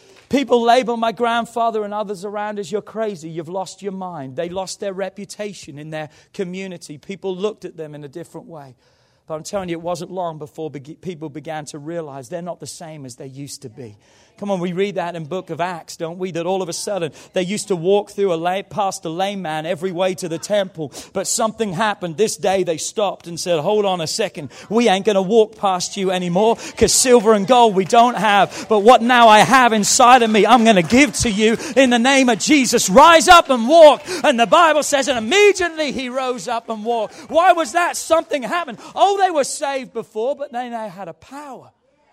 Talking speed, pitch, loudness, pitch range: 225 wpm, 200 Hz, -16 LUFS, 170-235 Hz